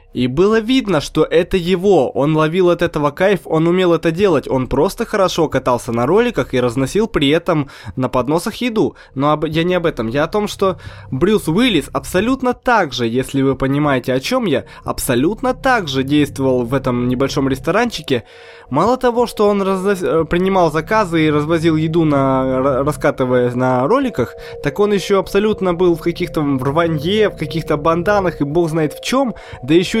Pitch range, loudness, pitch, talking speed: 135-195 Hz, -16 LUFS, 165 Hz, 180 wpm